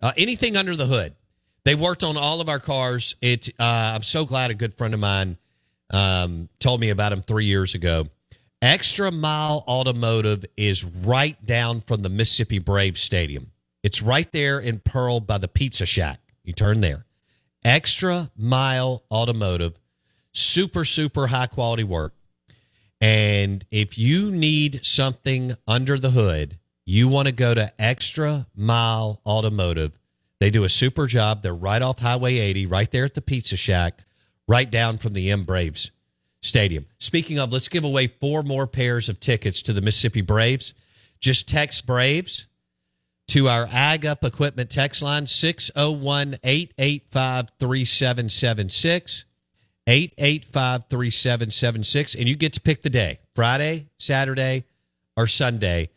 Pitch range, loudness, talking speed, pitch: 100-135 Hz, -21 LUFS, 150 wpm, 120 Hz